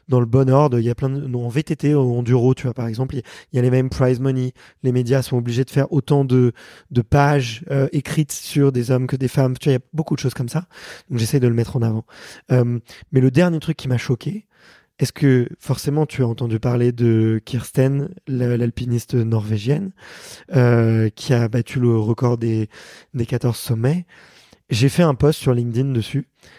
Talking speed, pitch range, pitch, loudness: 225 wpm, 120-140 Hz, 130 Hz, -19 LUFS